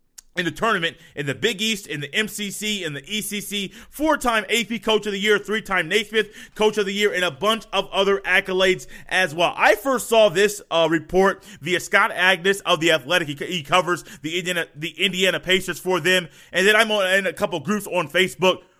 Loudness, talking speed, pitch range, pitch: -21 LUFS, 205 wpm, 175-210 Hz, 190 Hz